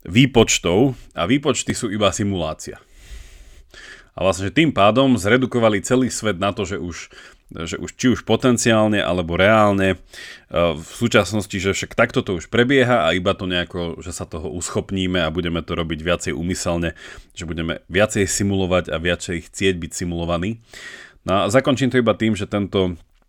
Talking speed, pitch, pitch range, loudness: 165 wpm, 95 Hz, 85-110 Hz, -19 LUFS